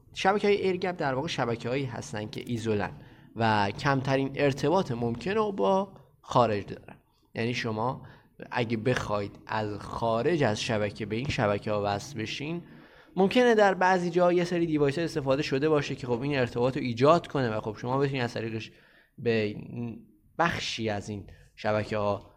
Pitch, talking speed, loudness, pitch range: 125 Hz, 160 wpm, -28 LUFS, 110-150 Hz